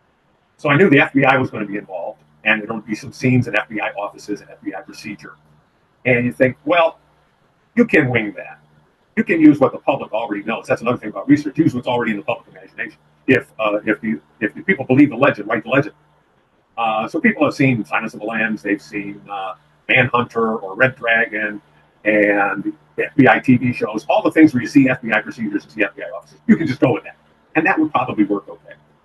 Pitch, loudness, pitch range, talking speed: 120 Hz, -17 LUFS, 105-140 Hz, 225 wpm